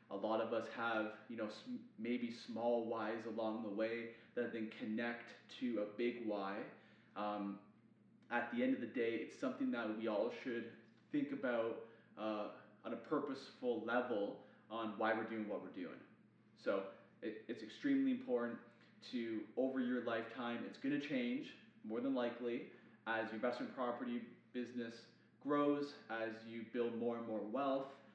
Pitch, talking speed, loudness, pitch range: 115 Hz, 160 wpm, -43 LUFS, 110-125 Hz